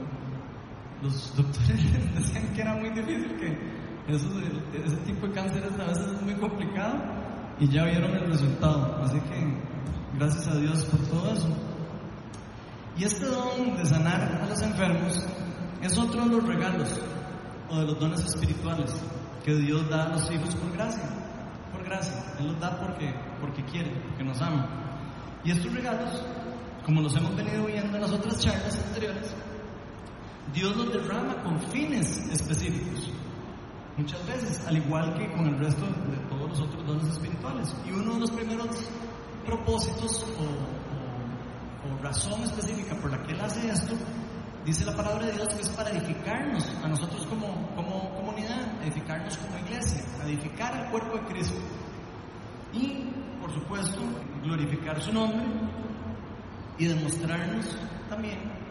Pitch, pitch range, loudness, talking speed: 165 Hz, 145-205 Hz, -30 LUFS, 150 wpm